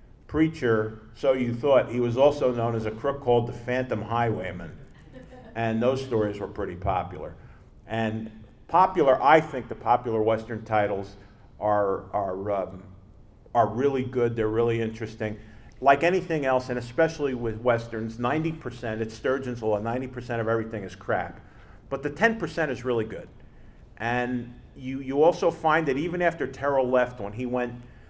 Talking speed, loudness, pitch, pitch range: 160 wpm, -26 LUFS, 120 Hz, 110-130 Hz